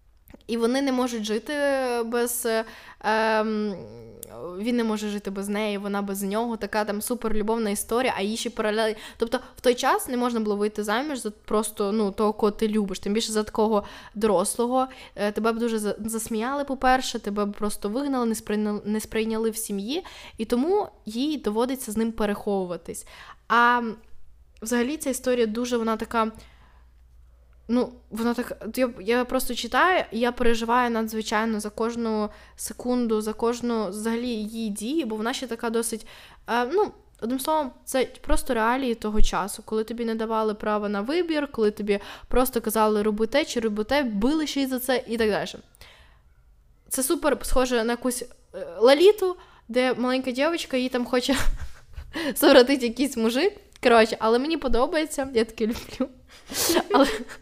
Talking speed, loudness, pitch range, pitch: 155 wpm, -25 LUFS, 215-255 Hz, 230 Hz